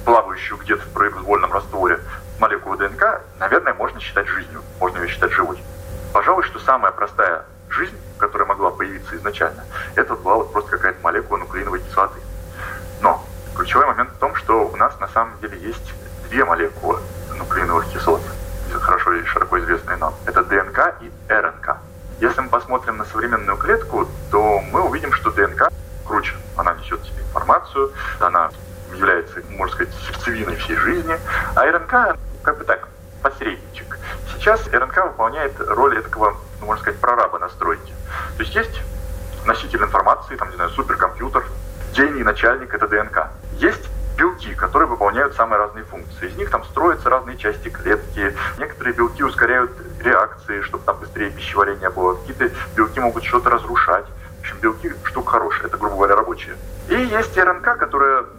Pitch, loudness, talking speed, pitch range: 90 Hz, -19 LUFS, 155 wpm, 85-105 Hz